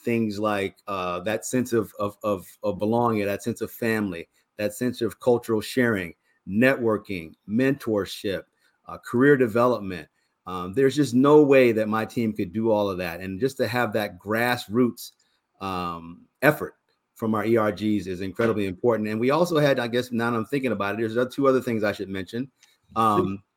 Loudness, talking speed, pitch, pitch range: -24 LUFS, 180 wpm, 110 Hz, 100-120 Hz